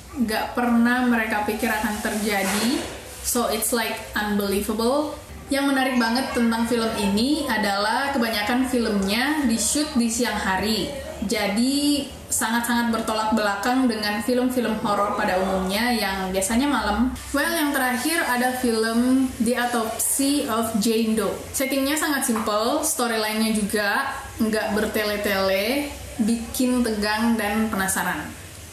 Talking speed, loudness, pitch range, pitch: 120 wpm, -22 LUFS, 210-255 Hz, 230 Hz